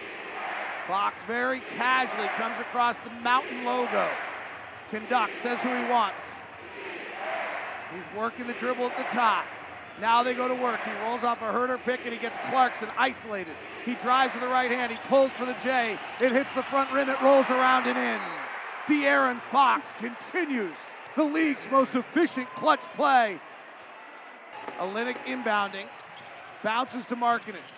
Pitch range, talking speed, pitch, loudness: 240-265 Hz, 155 wpm, 250 Hz, -27 LUFS